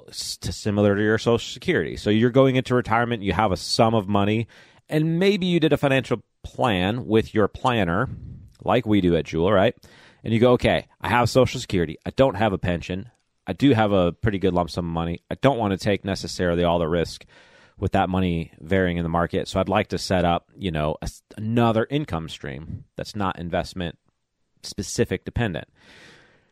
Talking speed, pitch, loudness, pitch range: 195 wpm, 100 Hz, -22 LUFS, 90-120 Hz